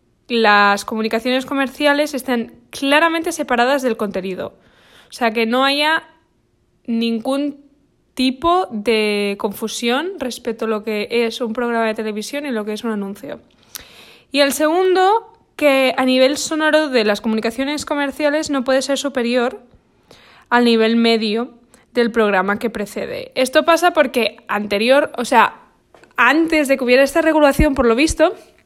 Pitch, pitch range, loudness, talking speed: 255 Hz, 230-290 Hz, -17 LUFS, 145 wpm